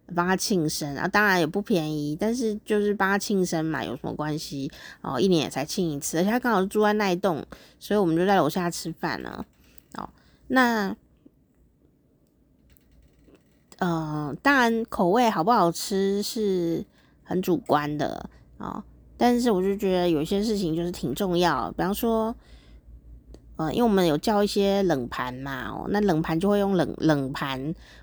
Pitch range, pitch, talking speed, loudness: 155-205 Hz, 180 Hz, 235 characters per minute, -25 LUFS